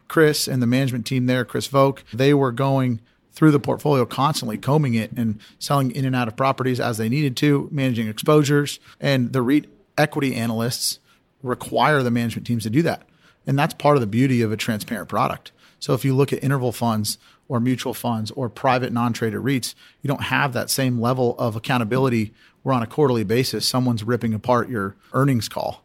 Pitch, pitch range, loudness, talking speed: 125 Hz, 115-135 Hz, -21 LUFS, 200 wpm